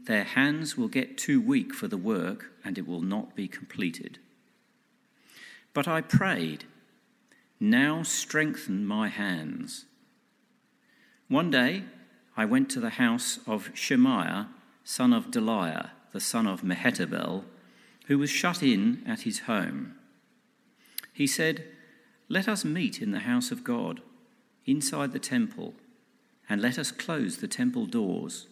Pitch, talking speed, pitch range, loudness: 240 Hz, 135 wpm, 215-250 Hz, -28 LUFS